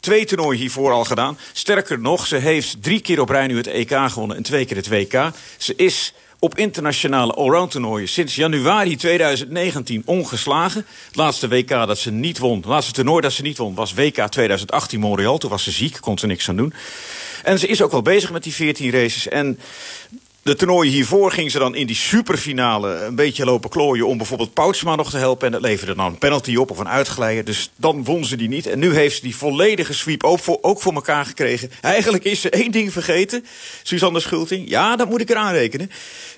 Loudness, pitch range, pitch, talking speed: -18 LUFS, 125-175 Hz, 145 Hz, 215 wpm